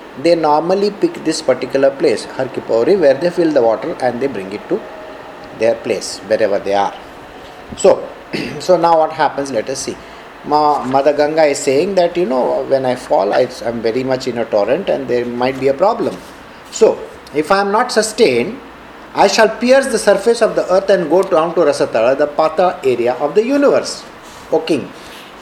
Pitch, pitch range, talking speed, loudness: 155 Hz, 130-195 Hz, 185 wpm, -15 LUFS